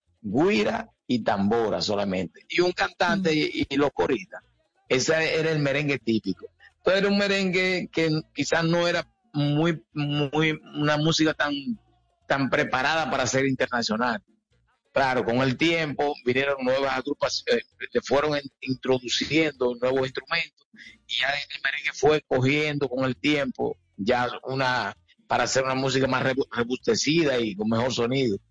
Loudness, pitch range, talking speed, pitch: -25 LUFS, 125-160 Hz, 140 wpm, 140 Hz